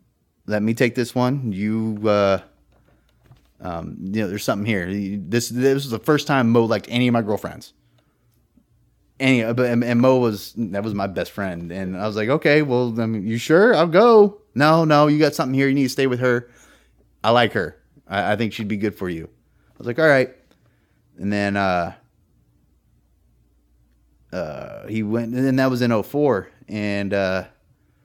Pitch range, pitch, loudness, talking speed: 100-125 Hz, 110 Hz, -20 LUFS, 185 wpm